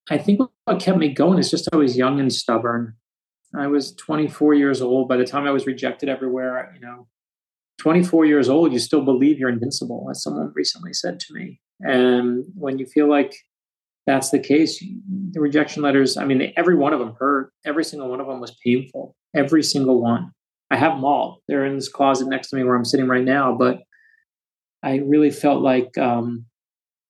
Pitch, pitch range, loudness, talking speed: 135 Hz, 125-150 Hz, -20 LUFS, 200 wpm